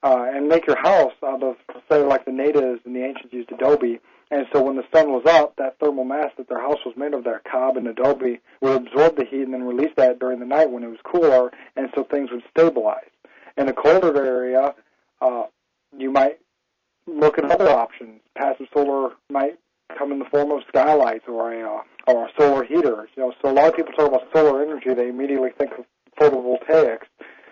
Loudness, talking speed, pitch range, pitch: -20 LUFS, 215 wpm, 125-145 Hz, 135 Hz